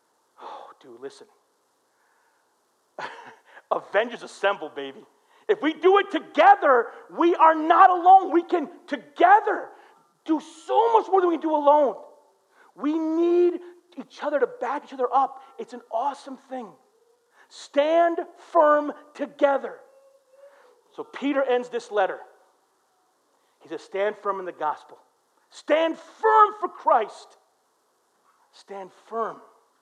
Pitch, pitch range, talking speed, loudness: 330 Hz, 270-425 Hz, 115 wpm, -22 LUFS